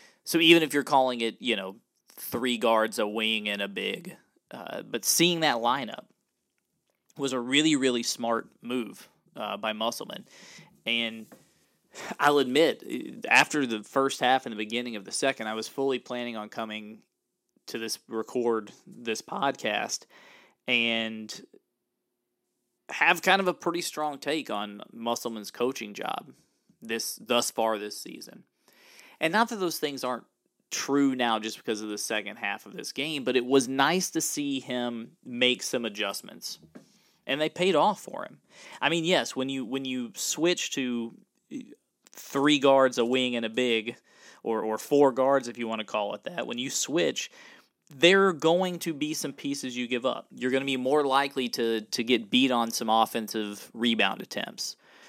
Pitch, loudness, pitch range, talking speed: 125 Hz, -27 LUFS, 115-140 Hz, 170 wpm